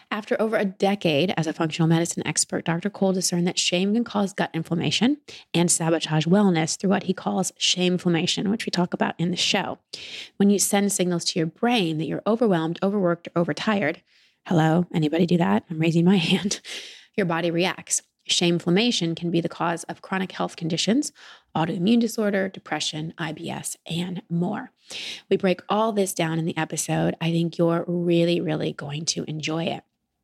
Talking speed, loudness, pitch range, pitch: 180 wpm, -23 LUFS, 165-200 Hz, 175 Hz